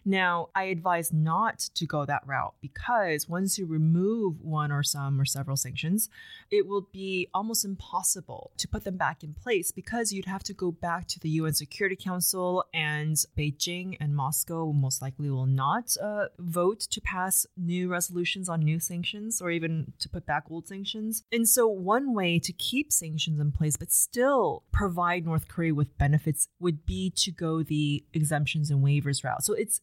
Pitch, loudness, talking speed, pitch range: 175 Hz, -28 LUFS, 185 wpm, 150-195 Hz